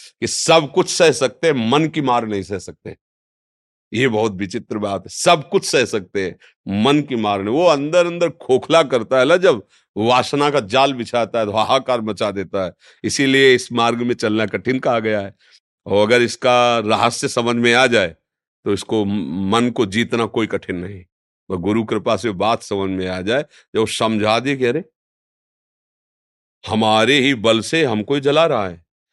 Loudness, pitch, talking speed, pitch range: -17 LUFS, 115 Hz, 185 wpm, 105-135 Hz